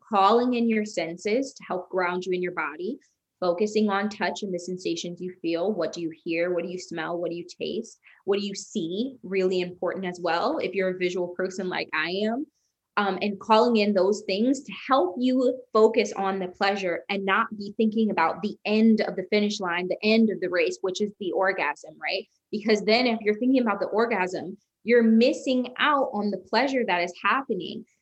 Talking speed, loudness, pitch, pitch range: 210 wpm, -25 LUFS, 195 Hz, 180-220 Hz